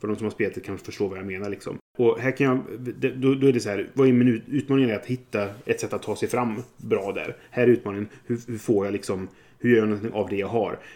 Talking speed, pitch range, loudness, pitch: 285 wpm, 100-130 Hz, -25 LUFS, 115 Hz